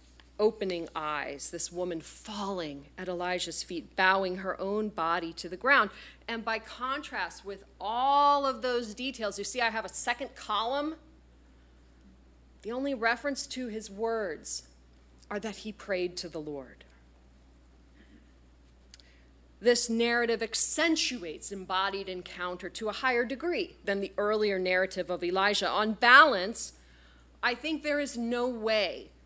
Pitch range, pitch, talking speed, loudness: 150-240 Hz, 195 Hz, 135 wpm, -29 LUFS